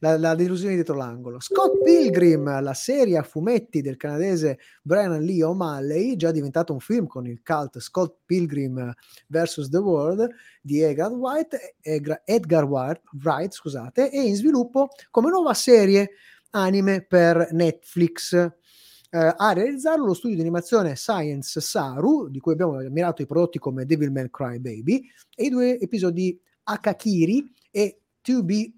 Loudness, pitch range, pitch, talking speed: -22 LUFS, 150-210 Hz, 170 Hz, 150 wpm